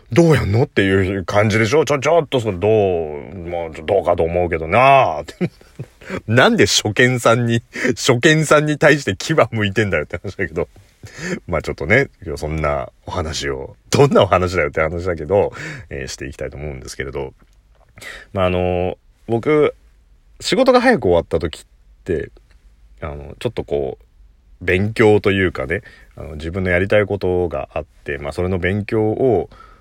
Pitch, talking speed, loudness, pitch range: 100 Hz, 315 characters per minute, -17 LUFS, 80-115 Hz